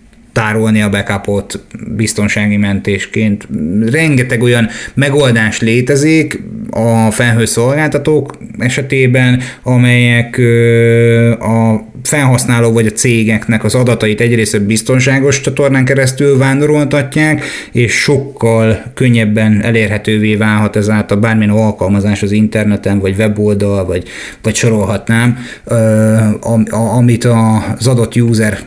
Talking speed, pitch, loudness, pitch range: 95 wpm, 115 Hz, -11 LUFS, 110-125 Hz